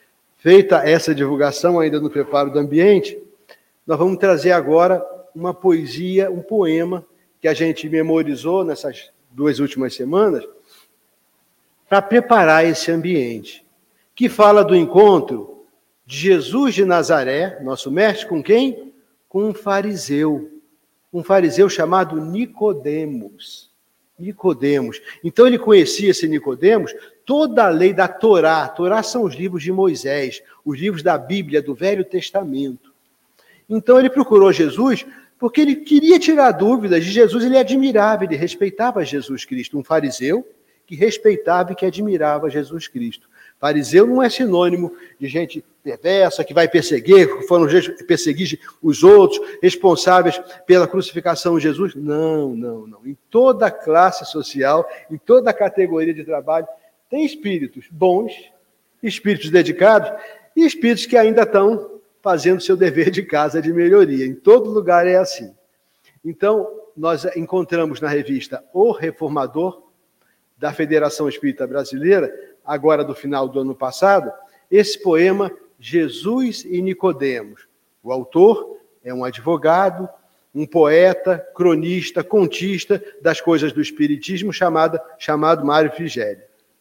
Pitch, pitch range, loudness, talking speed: 185 Hz, 155-230 Hz, -16 LUFS, 130 wpm